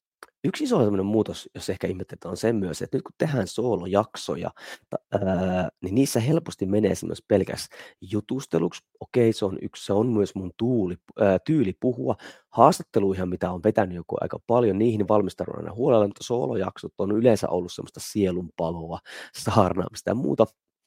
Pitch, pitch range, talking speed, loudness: 100 Hz, 95-110 Hz, 150 wpm, -25 LUFS